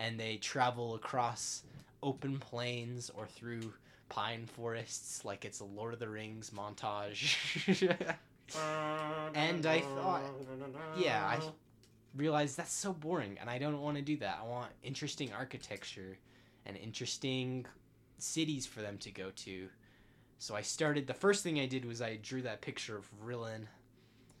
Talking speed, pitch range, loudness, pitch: 150 wpm, 115-145 Hz, -39 LUFS, 125 Hz